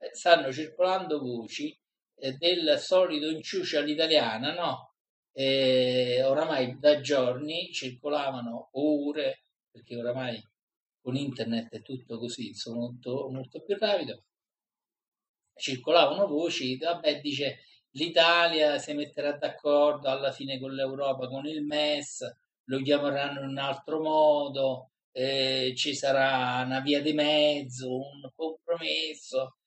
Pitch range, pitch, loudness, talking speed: 130-155 Hz, 140 Hz, -28 LUFS, 115 wpm